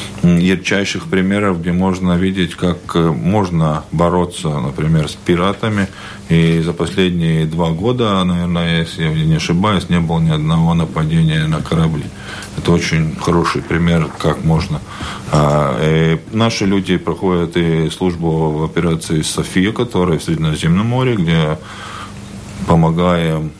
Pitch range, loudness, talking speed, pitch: 80-95 Hz, -15 LUFS, 125 wpm, 85 Hz